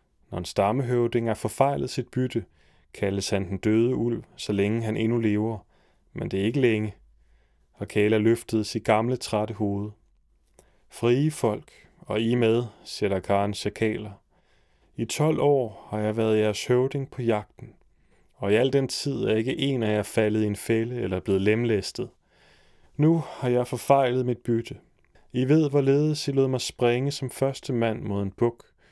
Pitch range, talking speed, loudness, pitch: 105-125 Hz, 170 wpm, -25 LUFS, 115 Hz